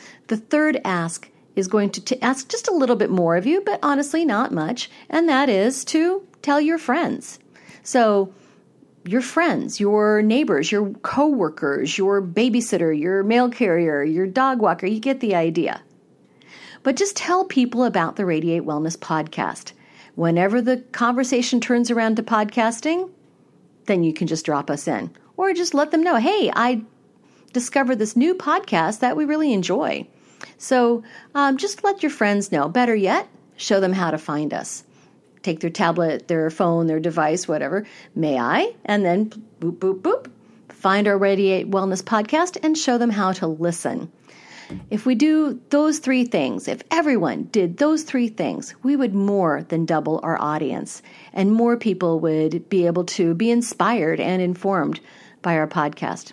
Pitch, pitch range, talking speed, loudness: 220 Hz, 175-270 Hz, 165 wpm, -21 LUFS